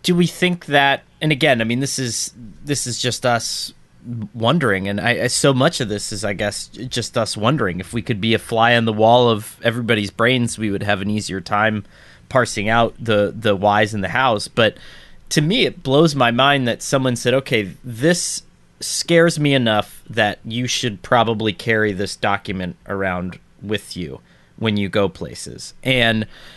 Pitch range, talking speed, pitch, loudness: 105-130 Hz, 185 wpm, 115 Hz, -18 LUFS